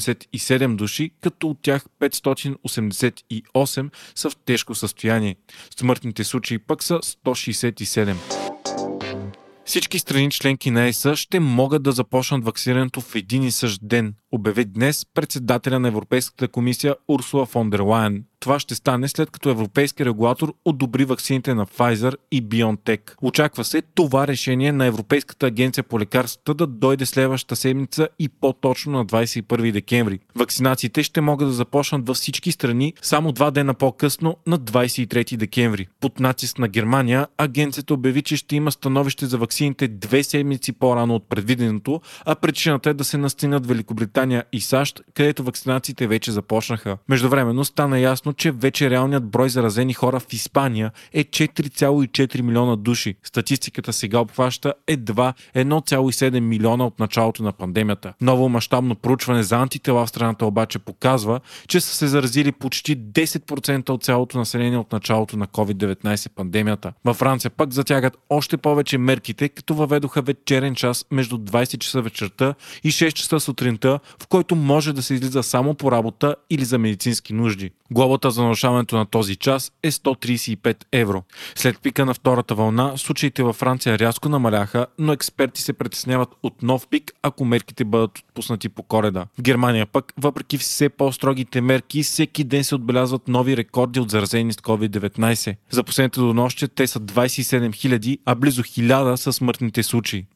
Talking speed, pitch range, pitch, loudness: 155 wpm, 115-140 Hz, 130 Hz, -21 LUFS